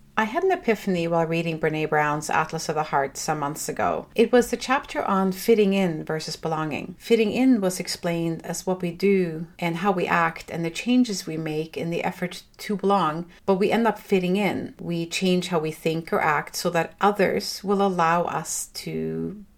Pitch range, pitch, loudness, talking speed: 165-200 Hz, 180 Hz, -24 LUFS, 200 wpm